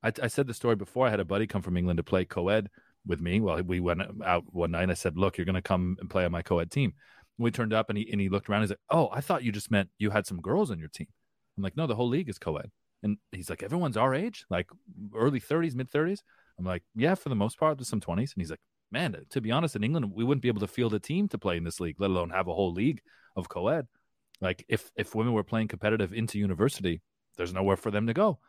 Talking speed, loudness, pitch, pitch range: 290 wpm, -30 LUFS, 105 Hz, 90-120 Hz